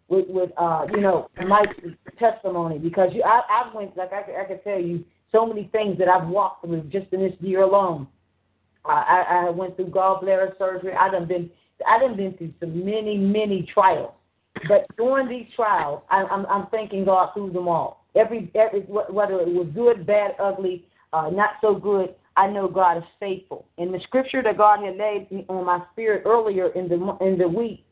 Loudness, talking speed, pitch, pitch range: -22 LUFS, 200 wpm, 190 Hz, 180-210 Hz